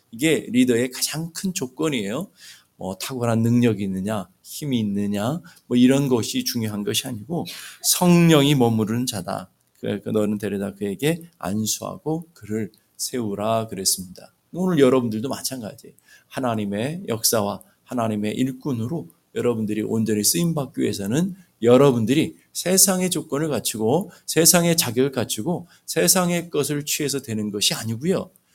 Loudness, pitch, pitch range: -22 LUFS, 125 Hz, 105-150 Hz